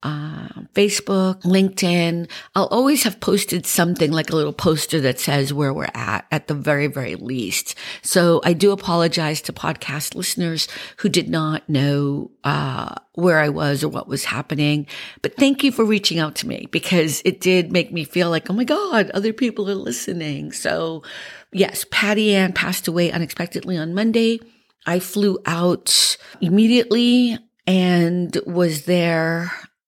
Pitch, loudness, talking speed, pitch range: 175 Hz, -19 LUFS, 160 wpm, 155-200 Hz